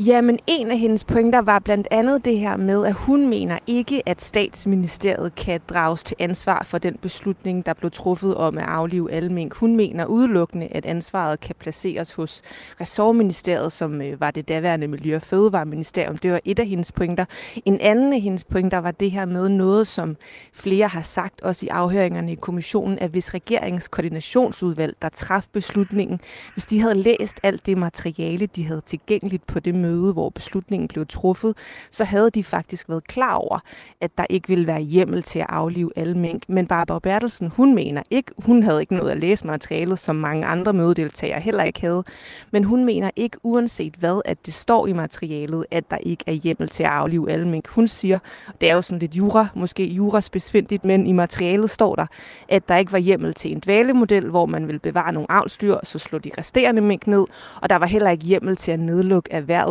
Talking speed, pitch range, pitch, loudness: 205 wpm, 170-205 Hz, 185 Hz, -21 LUFS